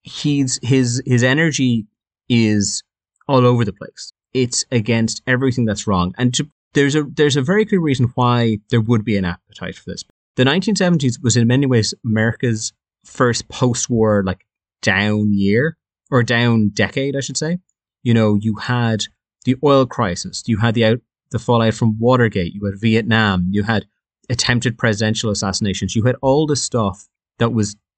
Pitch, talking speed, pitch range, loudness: 120 Hz, 170 wpm, 110-130 Hz, -17 LUFS